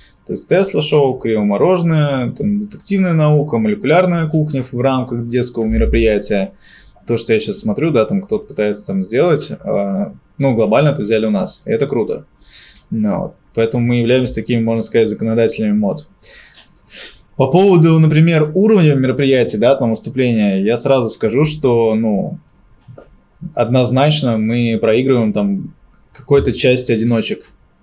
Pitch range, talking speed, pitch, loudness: 115-165 Hz, 135 wpm, 130 Hz, -15 LUFS